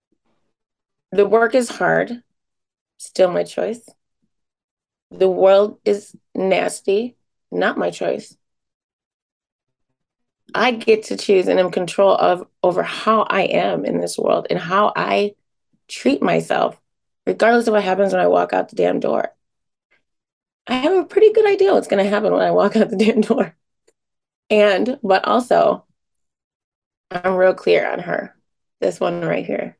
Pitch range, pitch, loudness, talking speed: 185-230 Hz, 205 Hz, -18 LUFS, 150 wpm